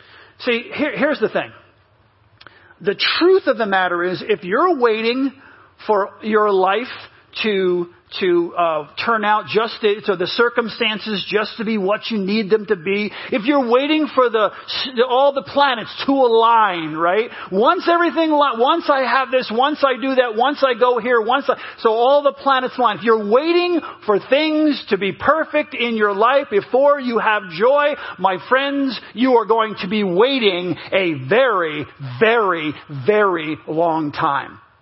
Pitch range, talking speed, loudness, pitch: 200-270 Hz, 165 wpm, -17 LUFS, 230 Hz